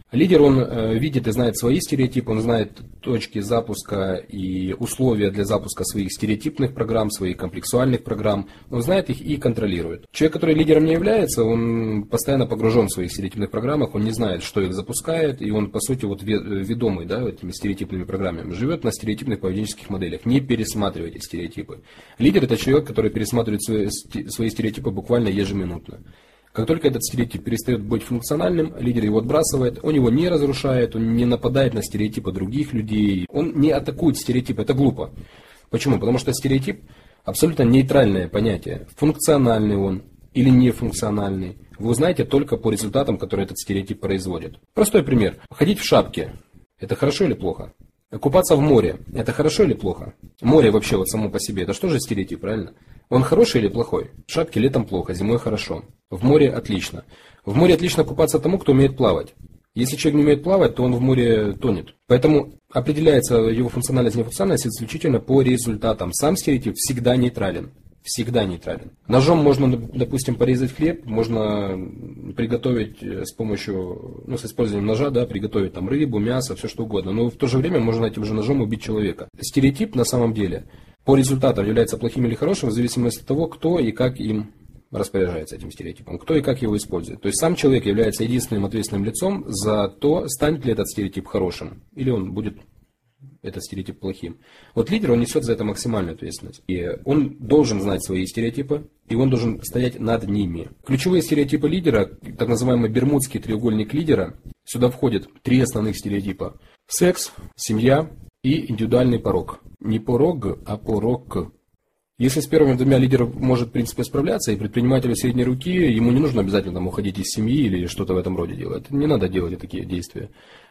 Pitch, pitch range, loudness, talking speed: 115 Hz, 105-135 Hz, -21 LUFS, 170 wpm